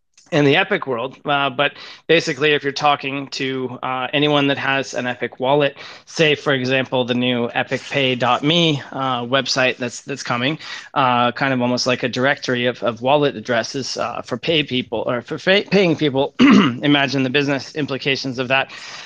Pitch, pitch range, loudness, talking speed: 135 Hz, 125-145 Hz, -18 LUFS, 175 wpm